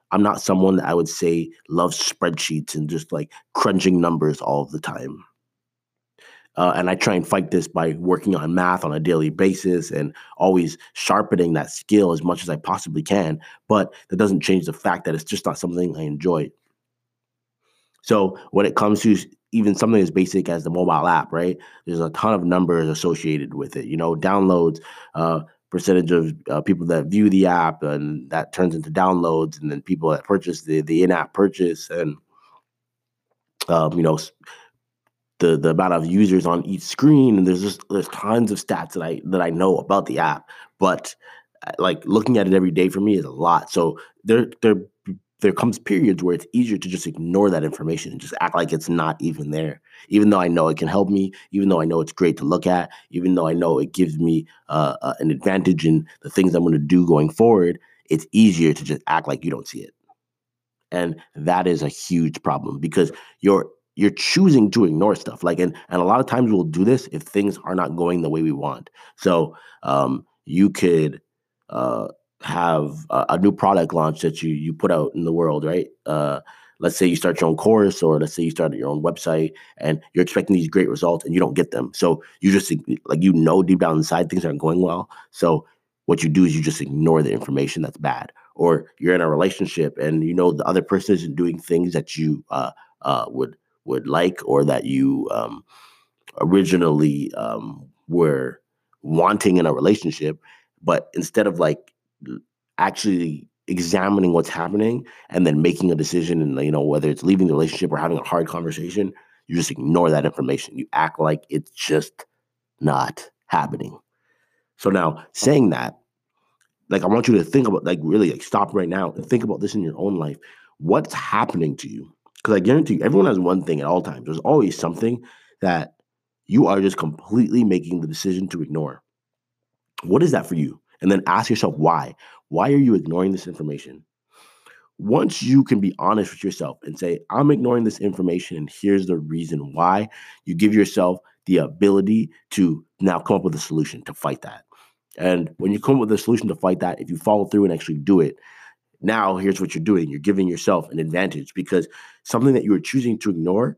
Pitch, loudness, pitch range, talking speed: 90 Hz, -20 LUFS, 80-95 Hz, 205 wpm